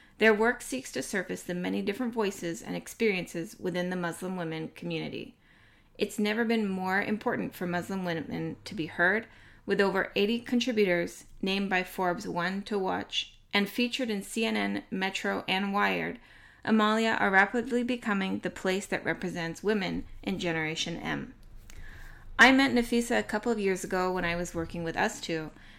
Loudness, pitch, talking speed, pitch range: -29 LUFS, 195 Hz, 165 wpm, 175-220 Hz